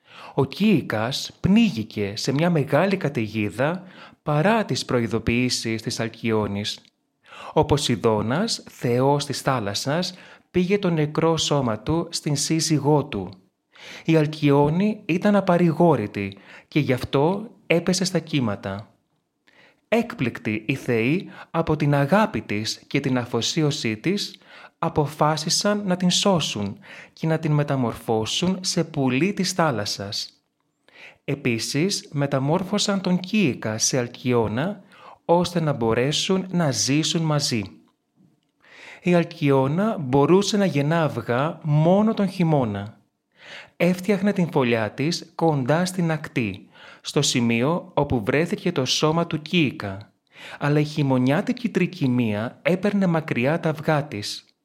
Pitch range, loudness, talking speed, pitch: 120-175 Hz, -22 LUFS, 115 wpm, 150 Hz